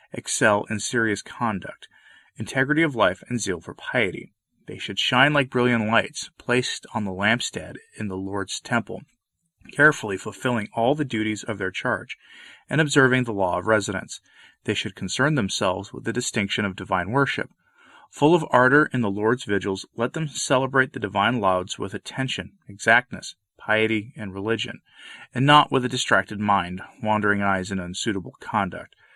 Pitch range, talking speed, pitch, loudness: 100-130 Hz, 165 wpm, 110 Hz, -23 LUFS